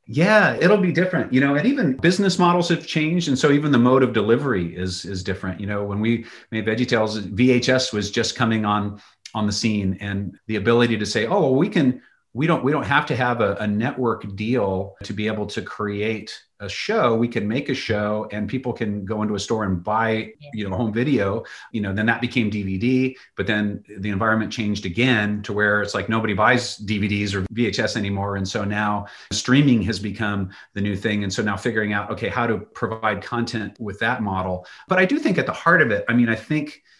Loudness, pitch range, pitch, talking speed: -21 LUFS, 105-120 Hz, 110 Hz, 225 wpm